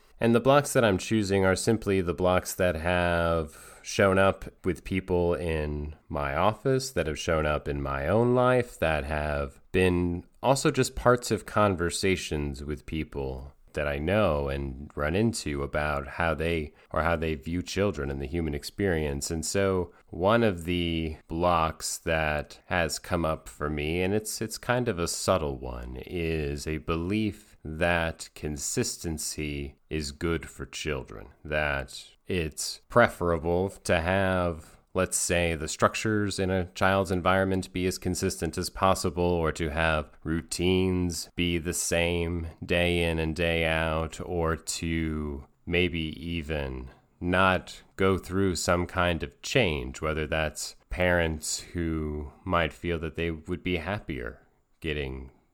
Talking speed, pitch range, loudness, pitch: 150 wpm, 75-95 Hz, -28 LUFS, 85 Hz